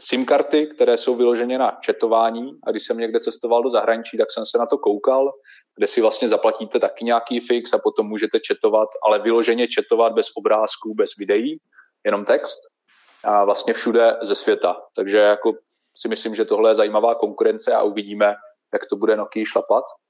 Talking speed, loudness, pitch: 180 wpm, -19 LUFS, 135 Hz